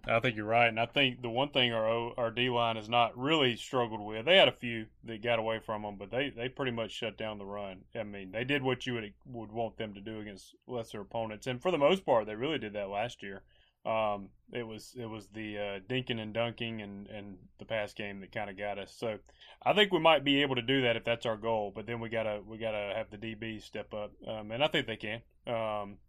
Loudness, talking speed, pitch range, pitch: -32 LUFS, 265 wpm, 105-120 Hz, 115 Hz